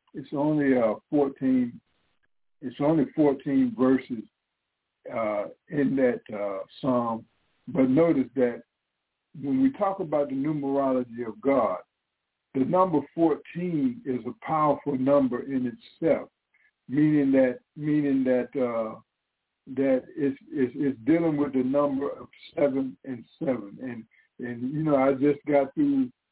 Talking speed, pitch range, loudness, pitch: 130 wpm, 125-150 Hz, -26 LUFS, 135 Hz